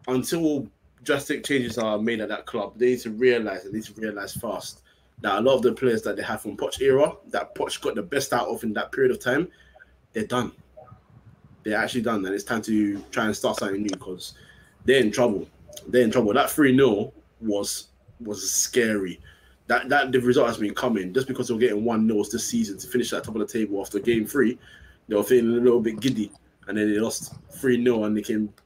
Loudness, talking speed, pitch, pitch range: -24 LUFS, 230 wpm, 110 Hz, 105-125 Hz